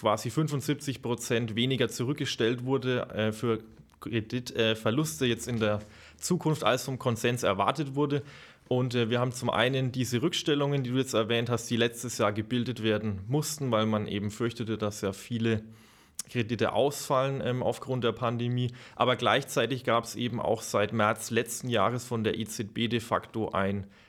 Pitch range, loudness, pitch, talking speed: 110-130 Hz, -29 LUFS, 120 Hz, 165 wpm